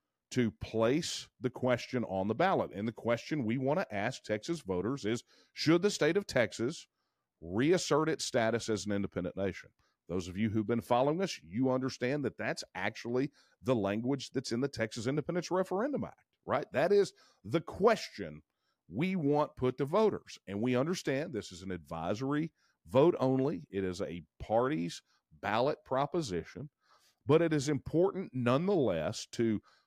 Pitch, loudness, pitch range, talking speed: 125 Hz, -33 LUFS, 105-150 Hz, 165 wpm